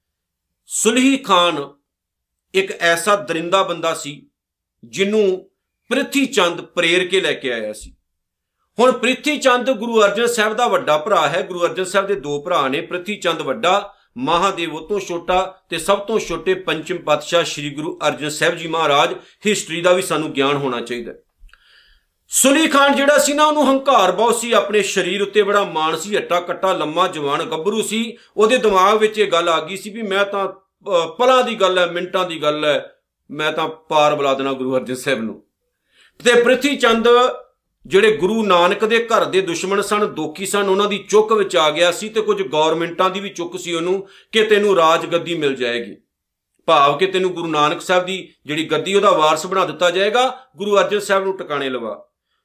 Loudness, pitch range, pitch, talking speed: -17 LUFS, 160-210 Hz, 185 Hz, 180 wpm